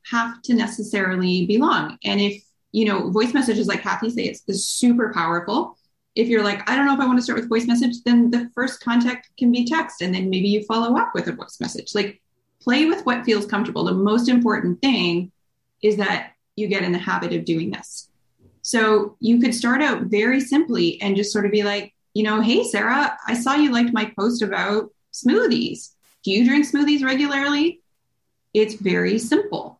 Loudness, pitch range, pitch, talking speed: -20 LUFS, 205-245 Hz, 225 Hz, 200 wpm